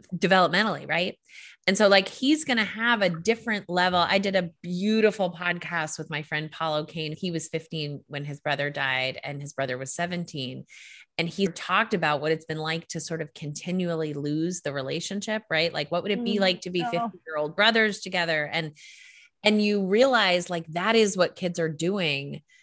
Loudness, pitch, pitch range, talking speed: -26 LUFS, 175 Hz, 155-195 Hz, 195 wpm